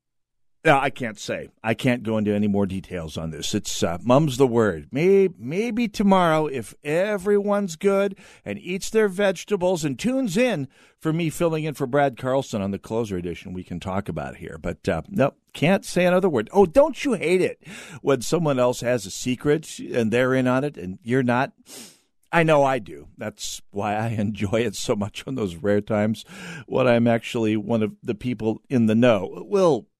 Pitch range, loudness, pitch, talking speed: 110-180 Hz, -23 LUFS, 130 Hz, 200 wpm